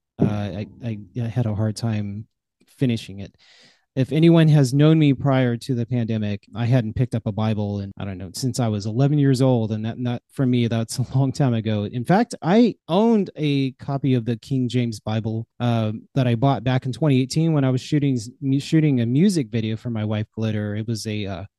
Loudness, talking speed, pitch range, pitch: -21 LUFS, 220 wpm, 110-135 Hz, 120 Hz